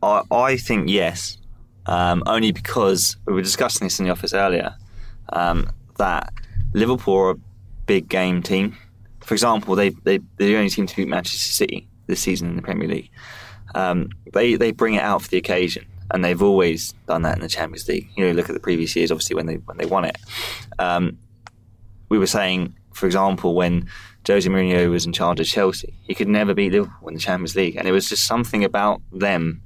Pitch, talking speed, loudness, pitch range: 95 Hz, 205 wpm, -20 LUFS, 90-105 Hz